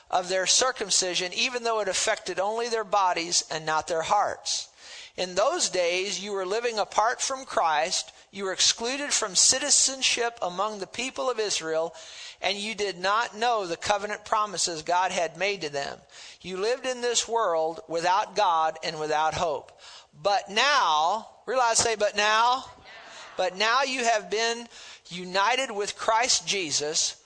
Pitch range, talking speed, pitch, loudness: 180-235 Hz, 155 wpm, 205 Hz, -25 LUFS